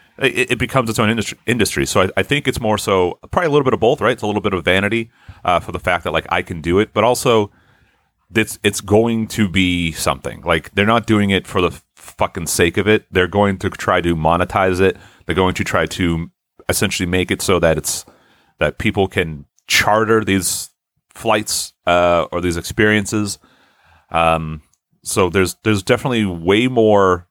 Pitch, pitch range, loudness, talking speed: 95 Hz, 90-110 Hz, -17 LUFS, 190 wpm